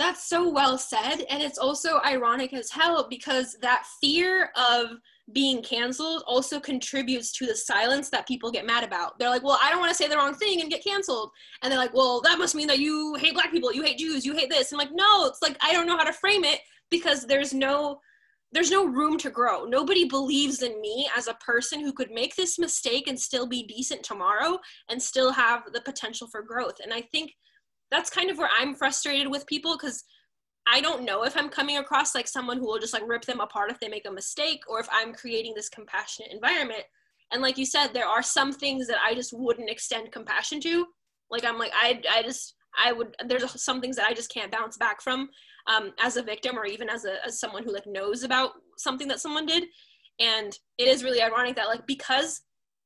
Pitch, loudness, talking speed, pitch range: 265 Hz, -25 LUFS, 230 wpm, 235-300 Hz